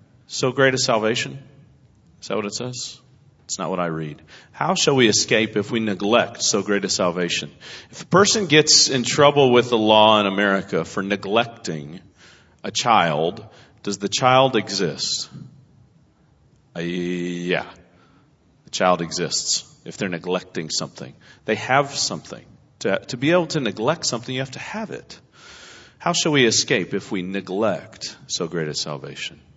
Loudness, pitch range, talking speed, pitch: -20 LUFS, 95-130 Hz, 160 wpm, 110 Hz